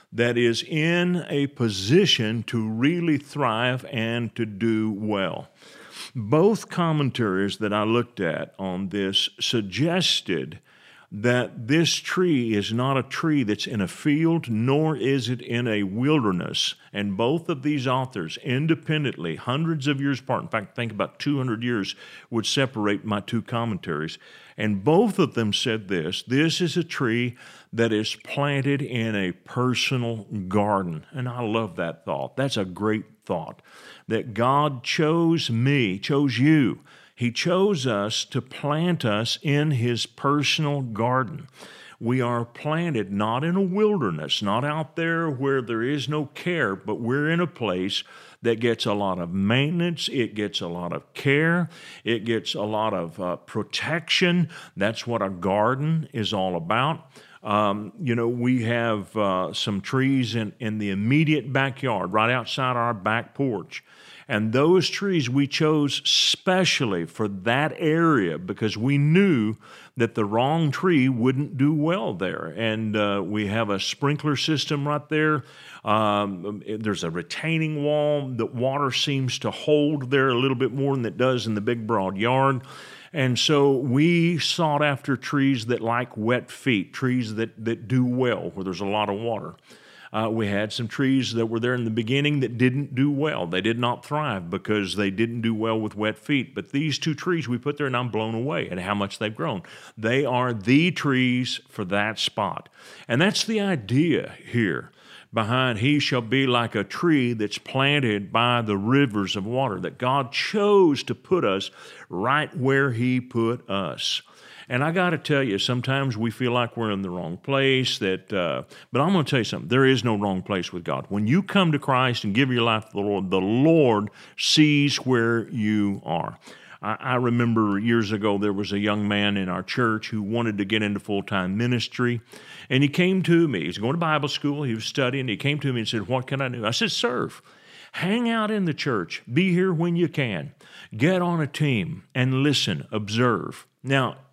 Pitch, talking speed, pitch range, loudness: 125 Hz, 180 wpm, 110-145 Hz, -24 LUFS